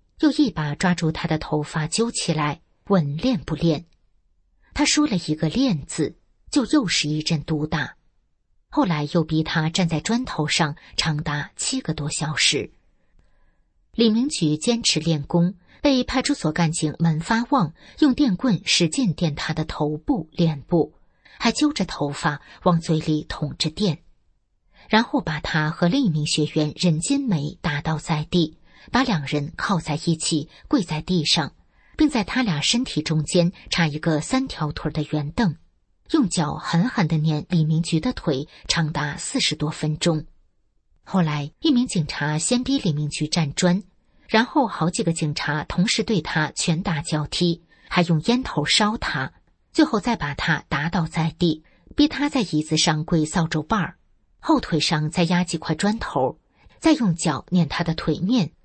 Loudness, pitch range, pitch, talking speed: -22 LUFS, 155-210 Hz, 165 Hz, 225 characters per minute